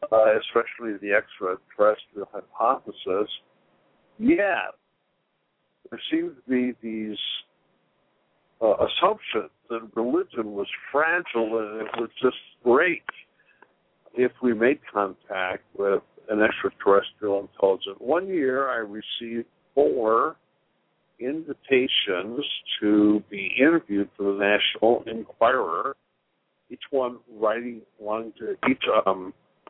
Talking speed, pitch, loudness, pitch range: 100 wpm, 115 Hz, -25 LUFS, 105-130 Hz